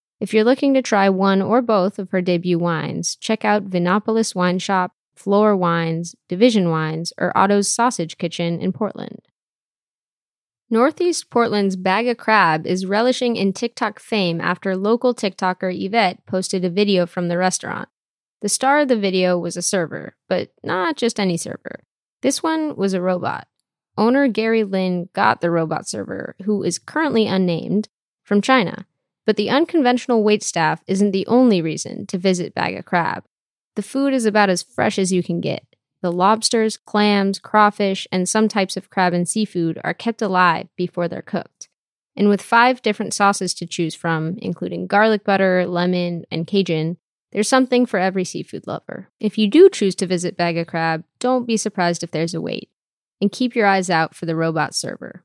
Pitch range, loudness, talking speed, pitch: 180-220 Hz, -19 LUFS, 175 wpm, 195 Hz